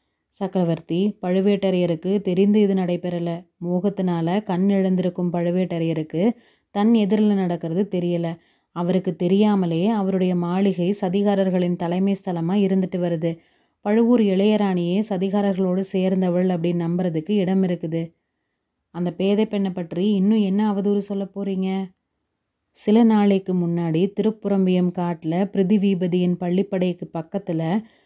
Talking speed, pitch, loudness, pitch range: 100 wpm, 190 Hz, -21 LUFS, 175-200 Hz